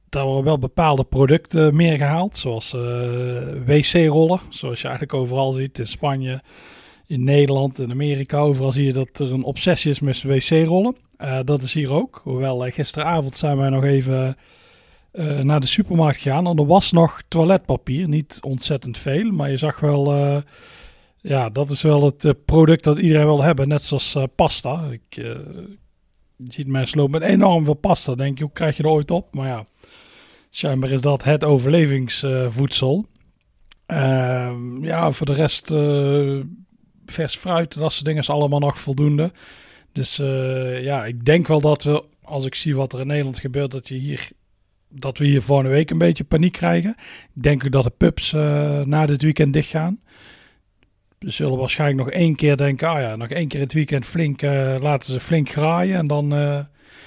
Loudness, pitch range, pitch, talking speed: -19 LUFS, 135-155 Hz, 145 Hz, 190 wpm